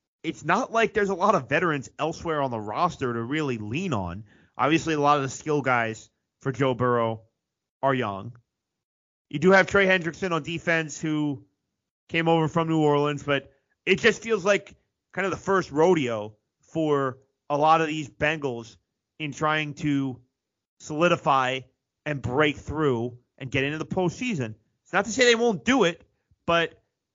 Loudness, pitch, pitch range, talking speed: -25 LUFS, 150 Hz, 125-165 Hz, 170 wpm